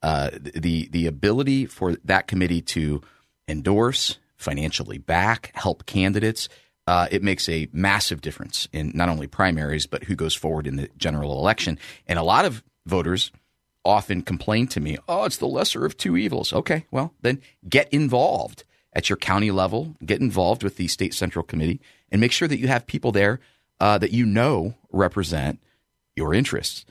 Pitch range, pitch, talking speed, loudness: 80-115 Hz, 95 Hz, 175 wpm, -23 LUFS